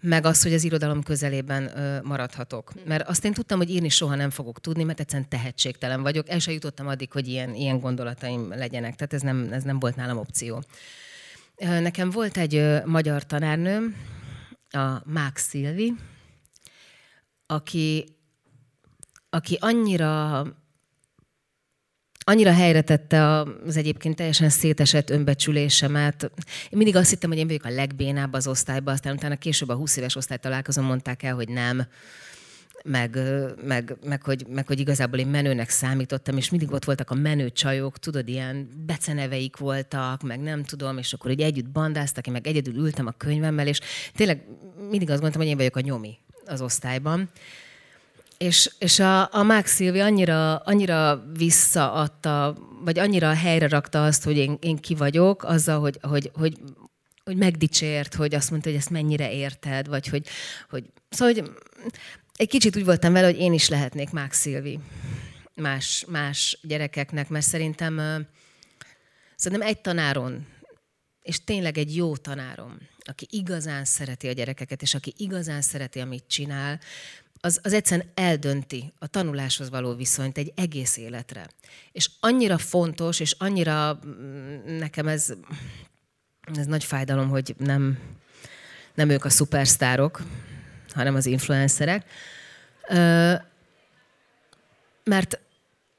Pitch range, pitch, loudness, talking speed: 135-160 Hz, 145 Hz, -23 LUFS, 140 wpm